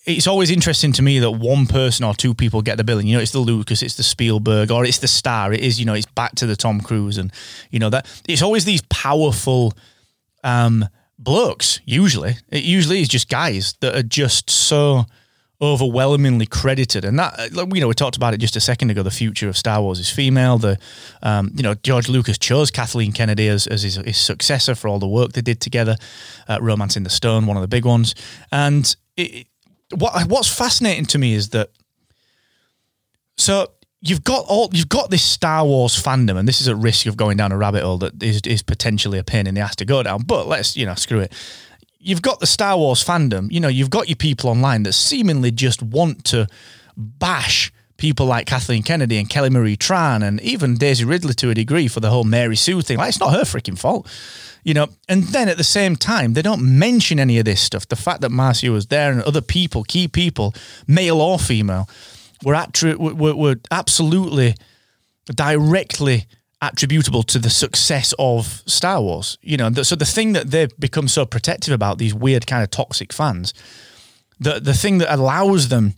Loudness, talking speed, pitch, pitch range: -17 LUFS, 210 wpm, 125 Hz, 110-150 Hz